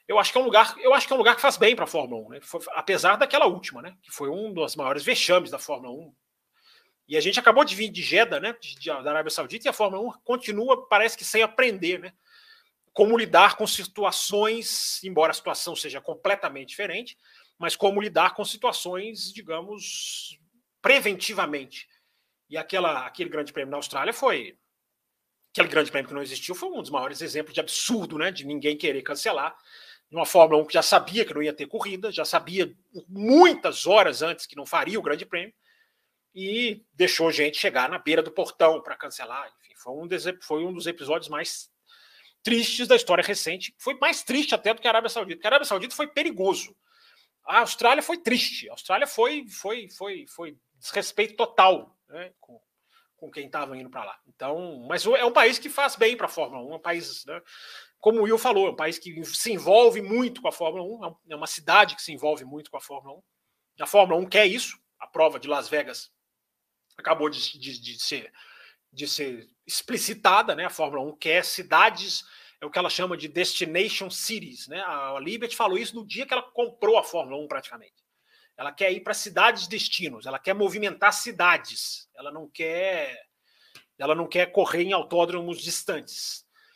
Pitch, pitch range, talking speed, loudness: 195 Hz, 165-235 Hz, 200 wpm, -24 LUFS